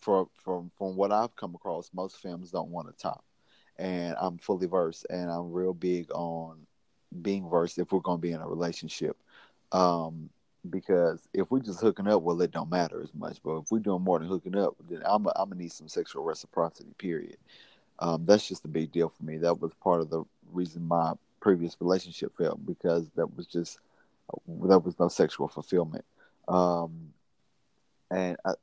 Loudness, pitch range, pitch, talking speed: -30 LUFS, 85-95 Hz, 90 Hz, 195 wpm